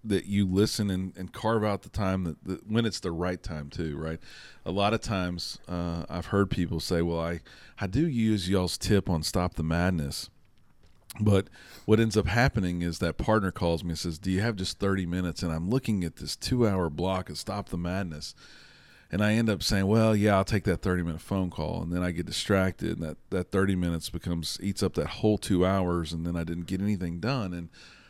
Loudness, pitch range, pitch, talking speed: -29 LUFS, 85-100 Hz, 95 Hz, 230 wpm